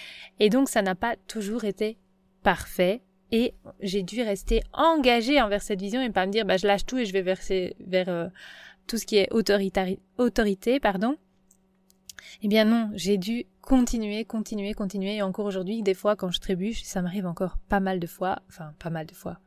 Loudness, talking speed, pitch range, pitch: -26 LUFS, 205 wpm, 190-225 Hz, 205 Hz